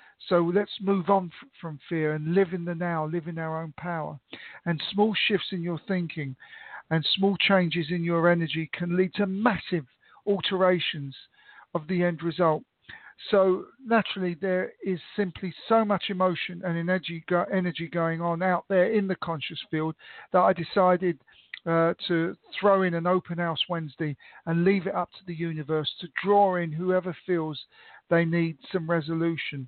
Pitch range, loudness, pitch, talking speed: 165-190 Hz, -27 LUFS, 175 Hz, 165 wpm